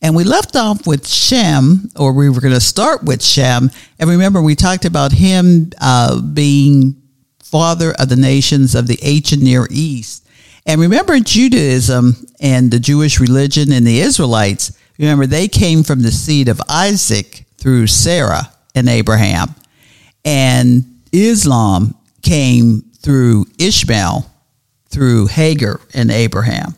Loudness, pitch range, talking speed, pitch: -11 LUFS, 120-155 Hz, 140 wpm, 135 Hz